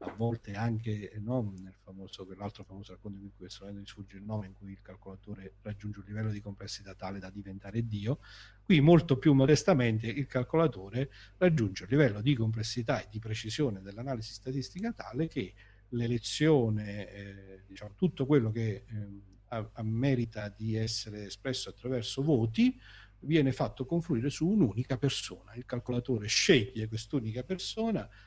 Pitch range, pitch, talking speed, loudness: 100-130 Hz, 110 Hz, 155 wpm, -31 LUFS